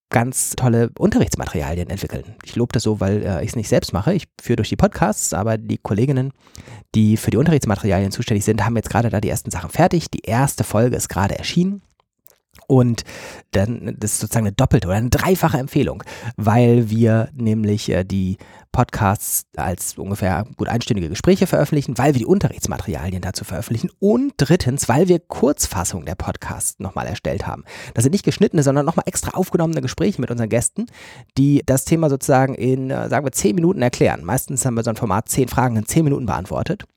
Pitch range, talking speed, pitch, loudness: 105-140 Hz, 185 wpm, 120 Hz, -19 LUFS